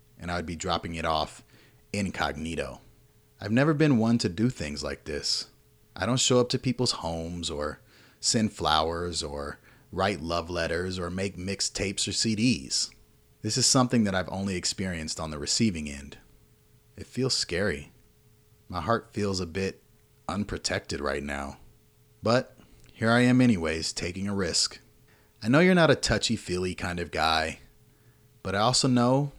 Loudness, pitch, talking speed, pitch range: -27 LUFS, 100 Hz, 165 wpm, 85-115 Hz